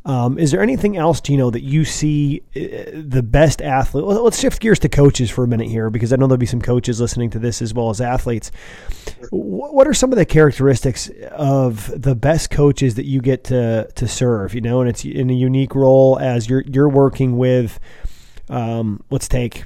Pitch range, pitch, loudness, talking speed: 120-145 Hz, 130 Hz, -16 LUFS, 210 wpm